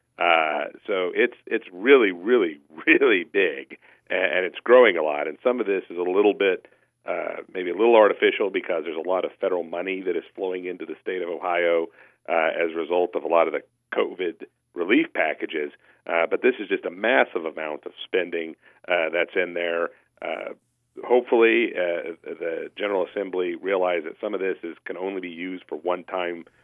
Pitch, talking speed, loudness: 390 Hz, 195 wpm, -23 LUFS